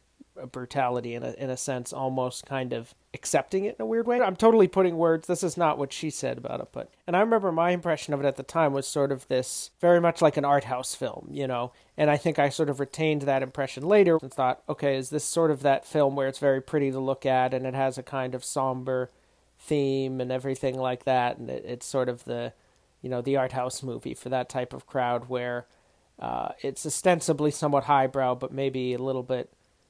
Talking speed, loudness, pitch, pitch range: 235 wpm, -27 LUFS, 135 Hz, 130-150 Hz